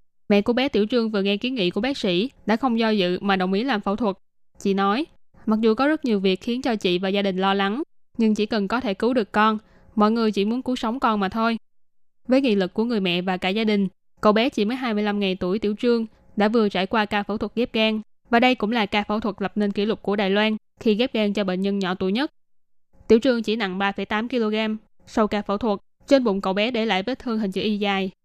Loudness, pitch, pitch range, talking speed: -22 LUFS, 210 Hz, 195-225 Hz, 270 wpm